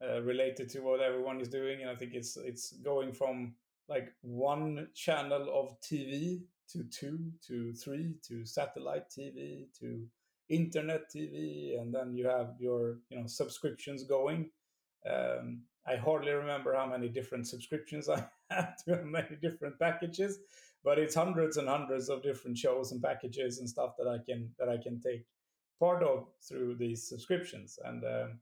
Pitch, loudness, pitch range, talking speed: 130 Hz, -37 LUFS, 120-155 Hz, 165 wpm